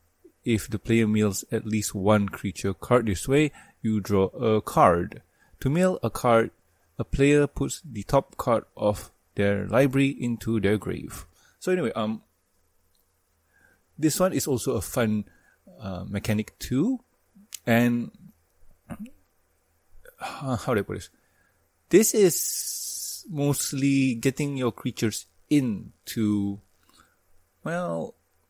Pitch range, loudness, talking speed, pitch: 100-140 Hz, -25 LUFS, 125 wpm, 115 Hz